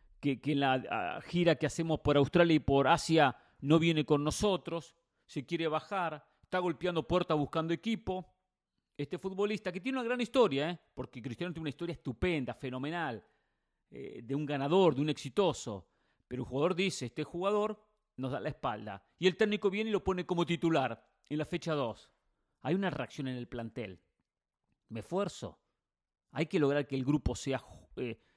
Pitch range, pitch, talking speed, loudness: 140-180 Hz, 155 Hz, 180 wpm, -33 LUFS